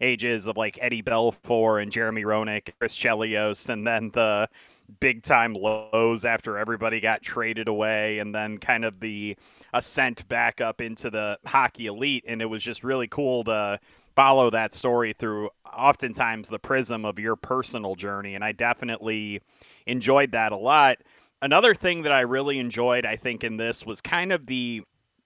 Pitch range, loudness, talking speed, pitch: 110-125 Hz, -24 LUFS, 170 wpm, 115 Hz